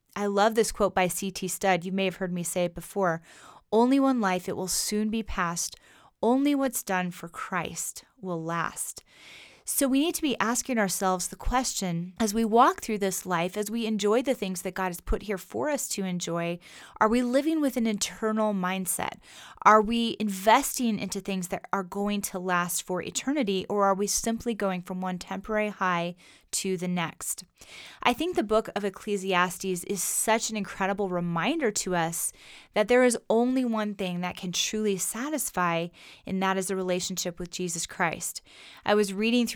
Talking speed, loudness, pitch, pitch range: 190 wpm, -27 LUFS, 200 Hz, 180-225 Hz